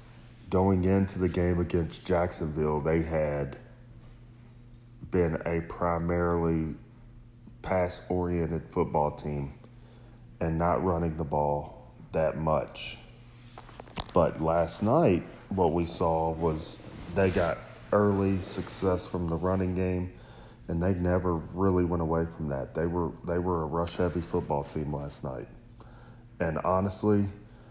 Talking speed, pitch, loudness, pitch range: 125 wpm, 90 Hz, -29 LUFS, 80-110 Hz